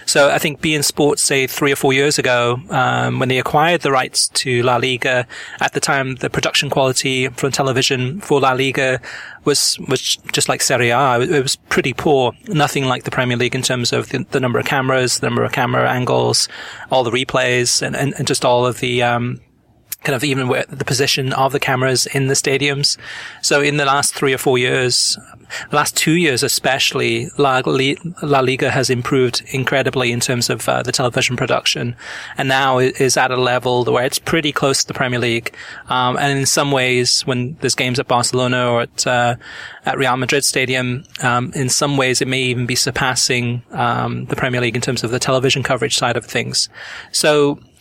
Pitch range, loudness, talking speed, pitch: 125-140 Hz, -16 LUFS, 205 wpm, 130 Hz